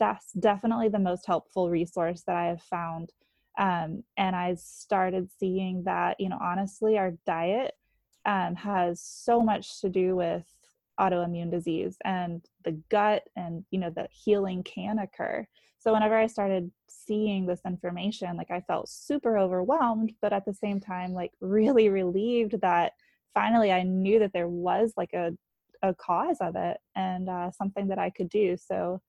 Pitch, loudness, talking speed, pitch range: 190 Hz, -28 LUFS, 165 wpm, 180-210 Hz